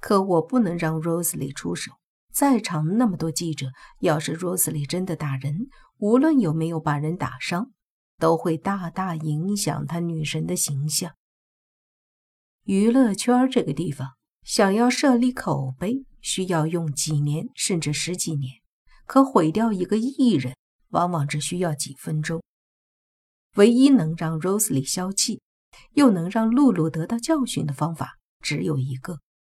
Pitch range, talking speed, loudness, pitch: 155-220 Hz, 225 characters per minute, -23 LUFS, 170 Hz